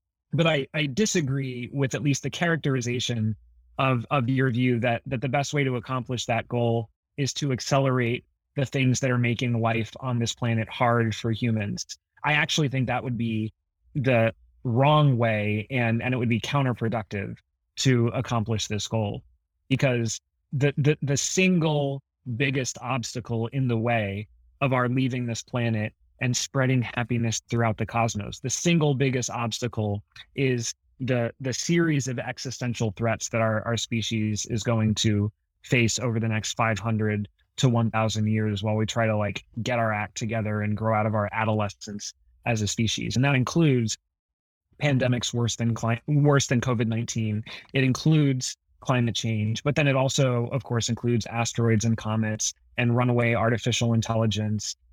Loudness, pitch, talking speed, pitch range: -25 LUFS, 120 Hz, 165 wpm, 110-130 Hz